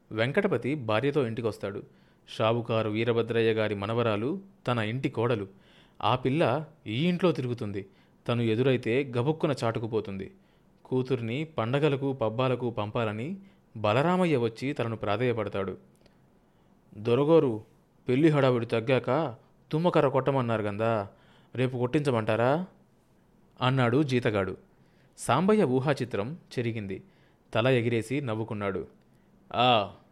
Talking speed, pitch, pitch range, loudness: 90 wpm, 120 Hz, 110-140 Hz, -28 LUFS